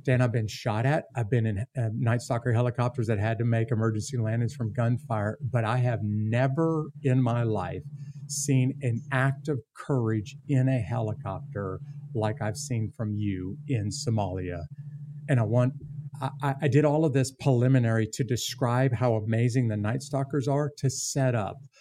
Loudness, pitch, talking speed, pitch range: -28 LUFS, 125 Hz, 175 wpm, 115-140 Hz